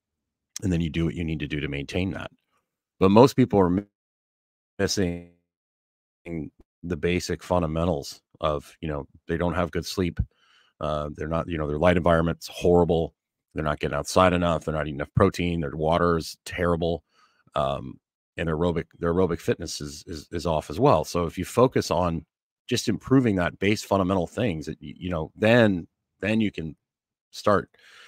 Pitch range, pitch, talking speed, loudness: 80-90 Hz, 85 Hz, 175 wpm, -25 LUFS